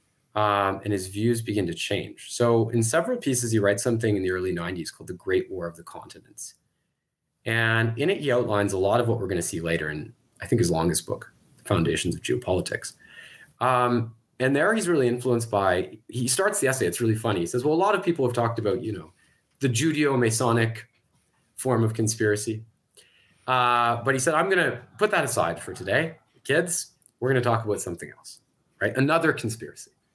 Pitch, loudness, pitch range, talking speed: 120 Hz, -24 LUFS, 110-130 Hz, 205 wpm